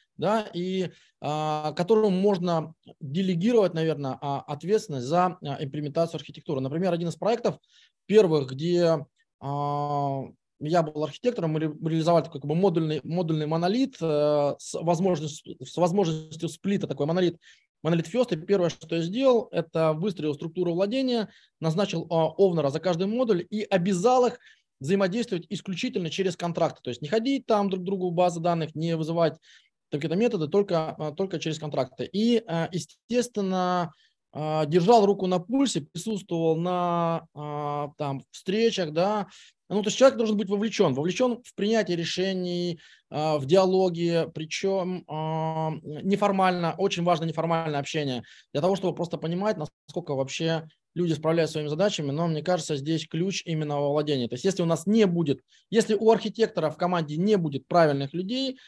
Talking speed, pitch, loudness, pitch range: 145 wpm, 170 Hz, -26 LUFS, 155-195 Hz